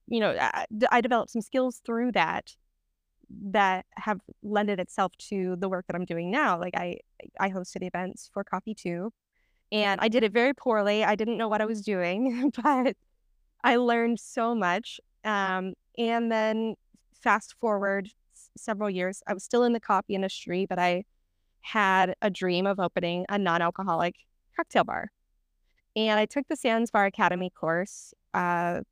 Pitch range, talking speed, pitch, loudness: 185-230 Hz, 165 wpm, 205 Hz, -28 LUFS